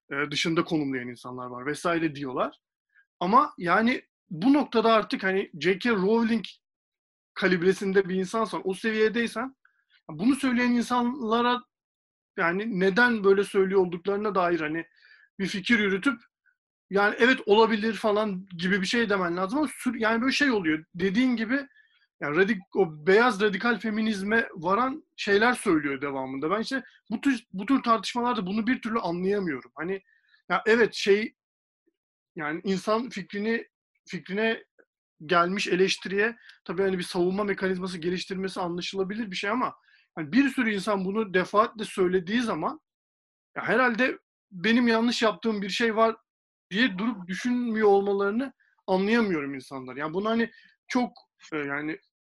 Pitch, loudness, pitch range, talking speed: 205 Hz, -26 LUFS, 185-235 Hz, 135 wpm